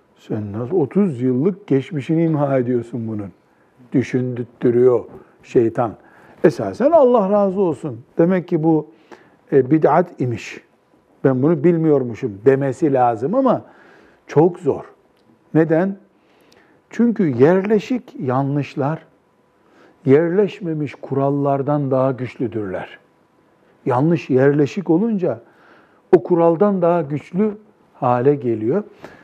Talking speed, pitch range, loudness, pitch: 90 wpm, 130-175 Hz, -18 LUFS, 150 Hz